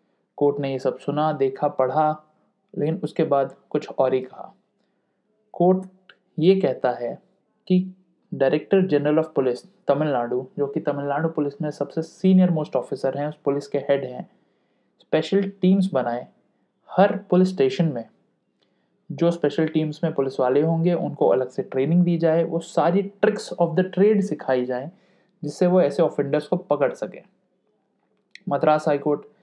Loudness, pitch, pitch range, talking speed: -22 LUFS, 155 Hz, 140-185 Hz, 155 wpm